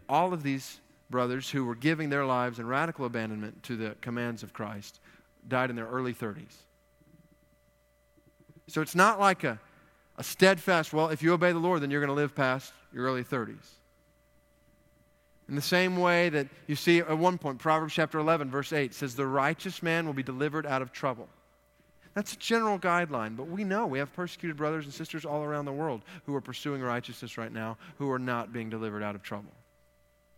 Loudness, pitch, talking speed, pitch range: -30 LUFS, 145 Hz, 200 wpm, 125-165 Hz